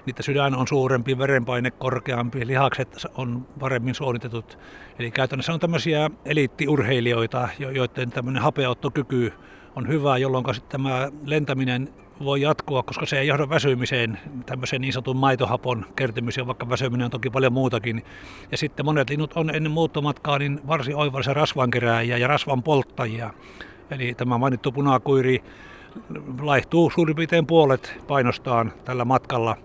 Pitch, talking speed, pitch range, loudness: 130 Hz, 135 wpm, 125-145 Hz, -23 LUFS